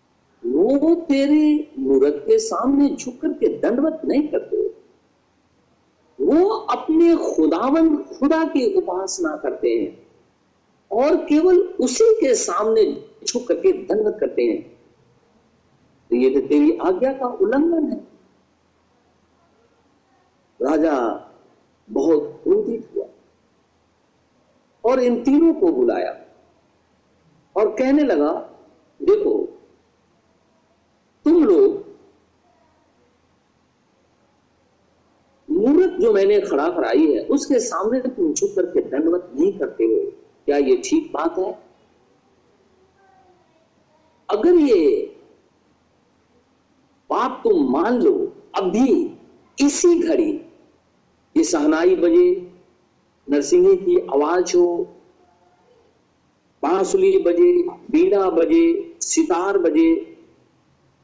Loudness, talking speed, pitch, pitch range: -19 LUFS, 90 wpm, 355 Hz, 315-395 Hz